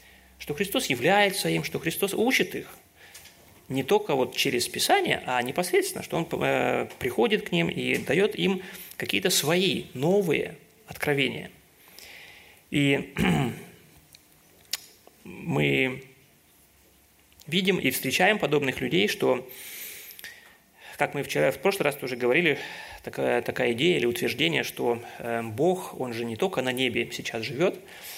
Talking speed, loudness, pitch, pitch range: 125 wpm, -26 LUFS, 145 Hz, 125-190 Hz